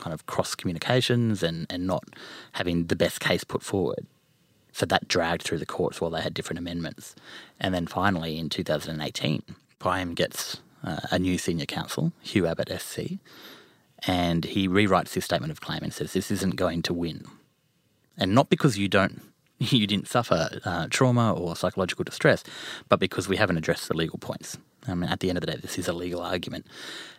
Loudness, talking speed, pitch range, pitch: -27 LUFS, 190 wpm, 85-100 Hz, 90 Hz